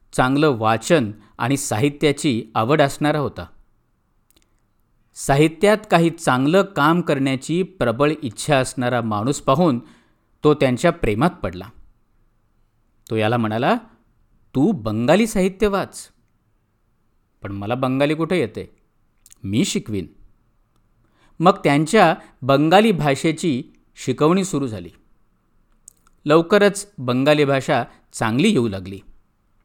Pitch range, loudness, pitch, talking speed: 110-155 Hz, -19 LUFS, 130 Hz, 95 wpm